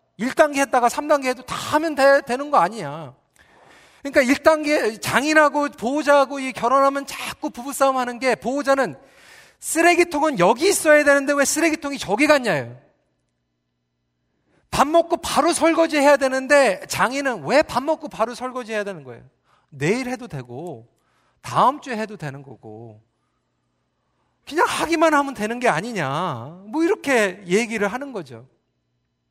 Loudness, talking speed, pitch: -19 LUFS, 305 characters per minute, 255 Hz